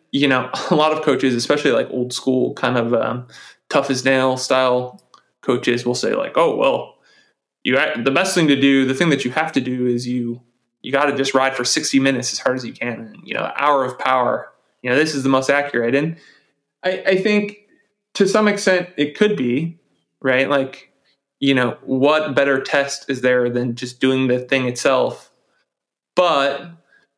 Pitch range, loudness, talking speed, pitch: 125-155 Hz, -18 LUFS, 200 wpm, 135 Hz